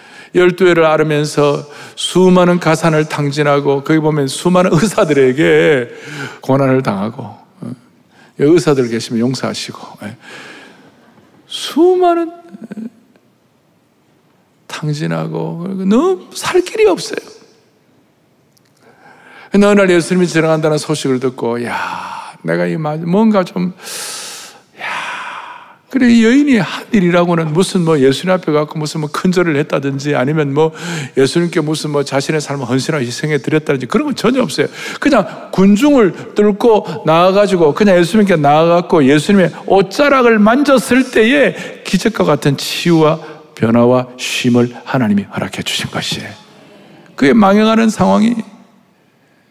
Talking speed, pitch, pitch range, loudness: 270 characters per minute, 175 Hz, 150-220 Hz, -13 LUFS